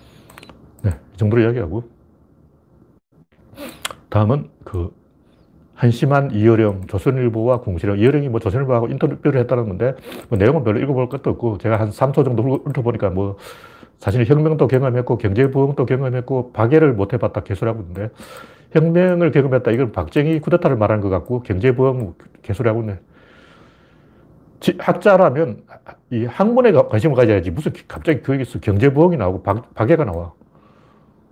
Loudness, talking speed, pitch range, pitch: -18 LUFS, 330 characters per minute, 105-140 Hz, 120 Hz